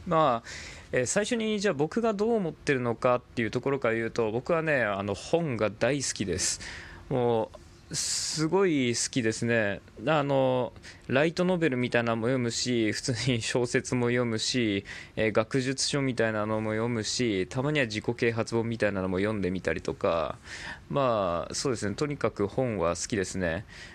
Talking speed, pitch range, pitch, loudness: 340 characters per minute, 110-135 Hz, 120 Hz, -28 LUFS